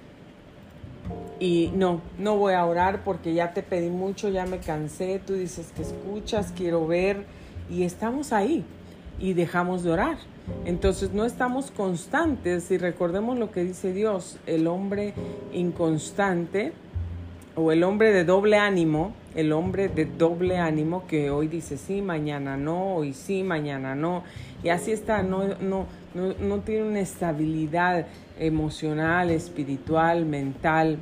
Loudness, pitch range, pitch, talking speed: -26 LUFS, 160-195 Hz, 175 Hz, 145 wpm